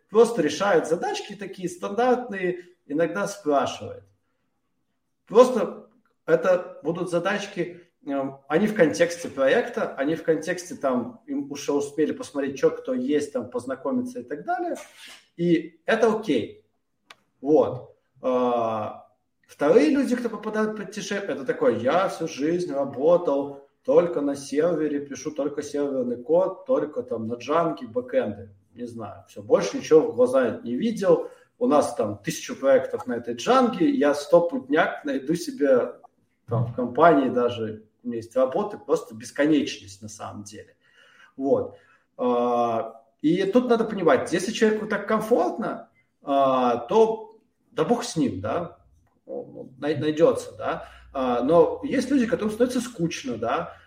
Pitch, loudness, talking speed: 180 Hz, -24 LUFS, 130 wpm